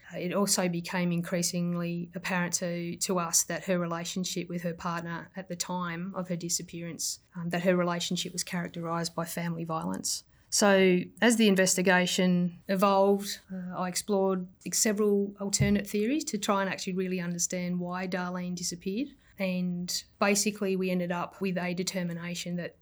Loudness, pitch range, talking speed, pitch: -29 LUFS, 175-190 Hz, 155 wpm, 180 Hz